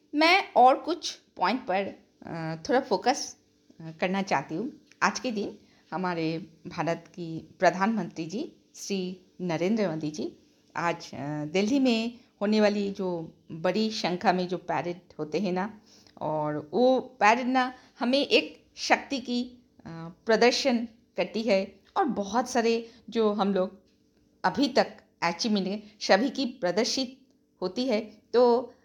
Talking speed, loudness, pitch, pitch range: 130 wpm, -27 LUFS, 205 Hz, 175-245 Hz